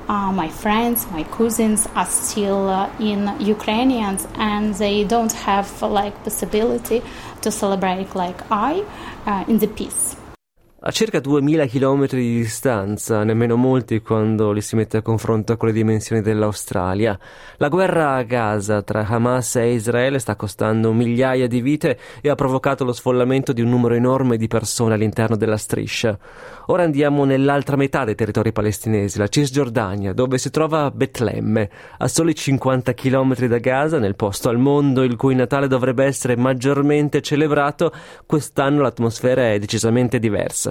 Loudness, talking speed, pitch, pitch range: -19 LUFS, 155 wpm, 130 Hz, 115-170 Hz